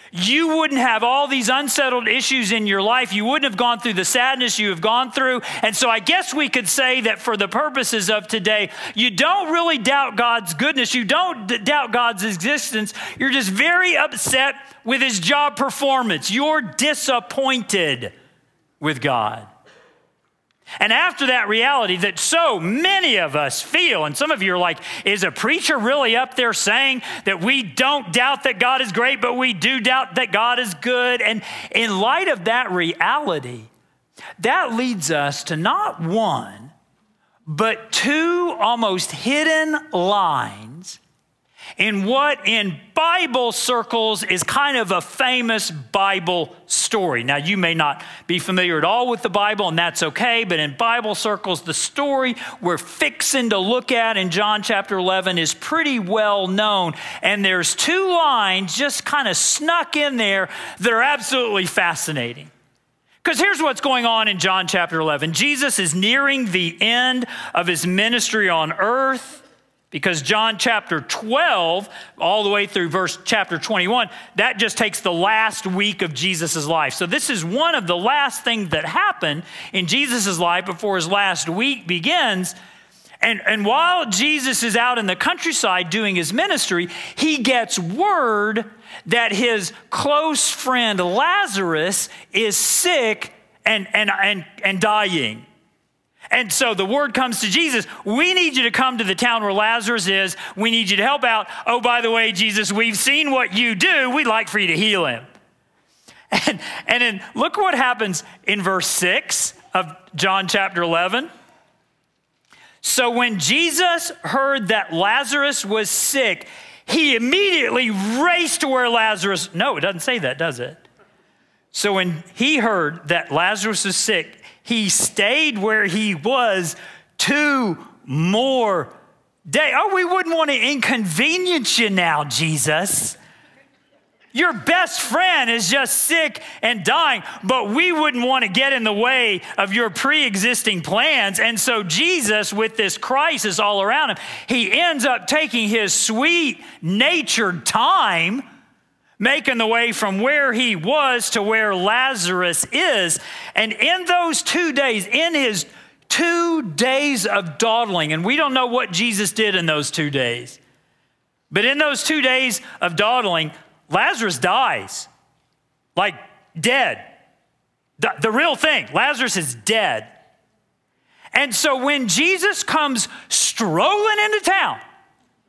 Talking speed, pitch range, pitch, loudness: 155 wpm, 195-270 Hz, 230 Hz, -18 LUFS